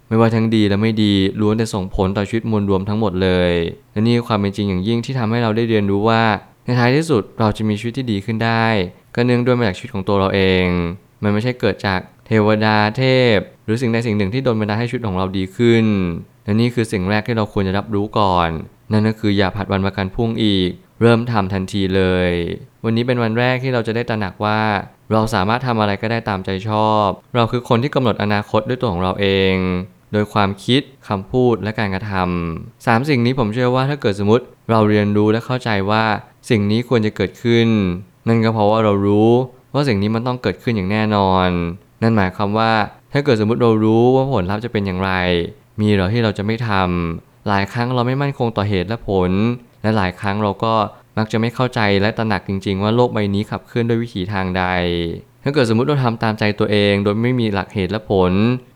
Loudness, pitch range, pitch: -18 LUFS, 100-120 Hz, 110 Hz